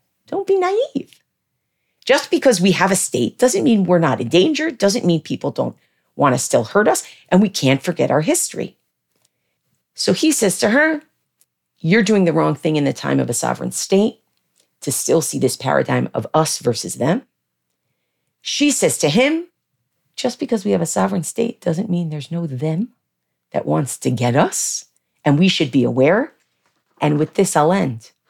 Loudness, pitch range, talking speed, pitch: -18 LUFS, 160-250 Hz, 185 wpm, 190 Hz